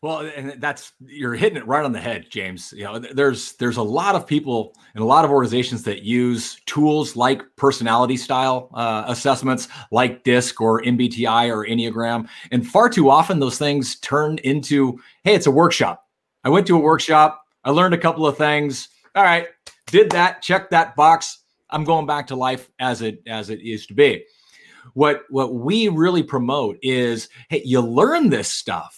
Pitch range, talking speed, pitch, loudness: 120-155 Hz, 190 wpm, 135 Hz, -19 LUFS